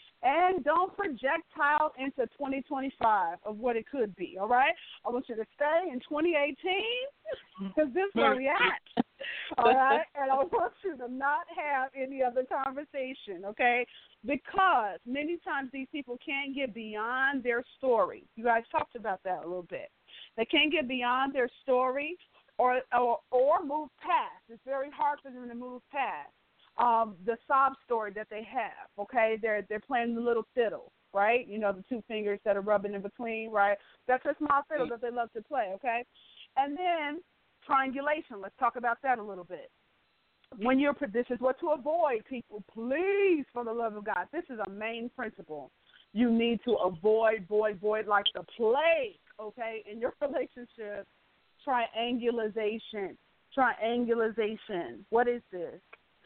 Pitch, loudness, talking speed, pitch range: 245 Hz, -31 LUFS, 165 wpm, 220-285 Hz